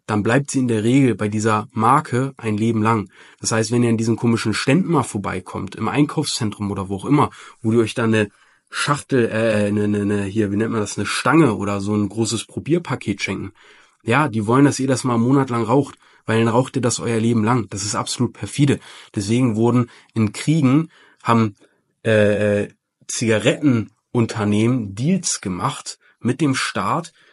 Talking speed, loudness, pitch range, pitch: 190 wpm, -19 LUFS, 105-130 Hz, 115 Hz